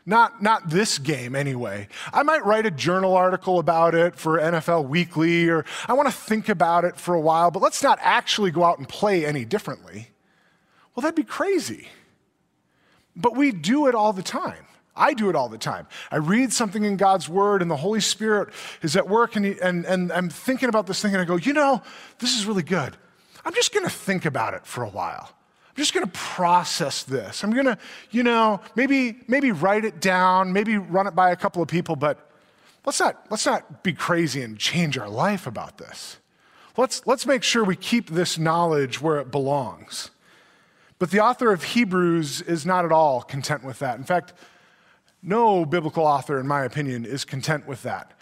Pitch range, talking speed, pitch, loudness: 160-220 Hz, 205 wpm, 185 Hz, -22 LUFS